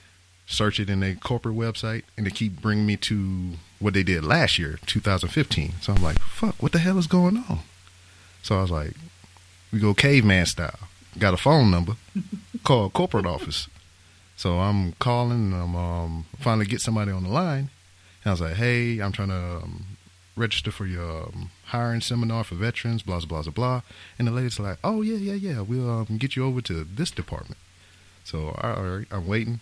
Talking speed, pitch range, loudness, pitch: 200 wpm, 90-120 Hz, -25 LUFS, 100 Hz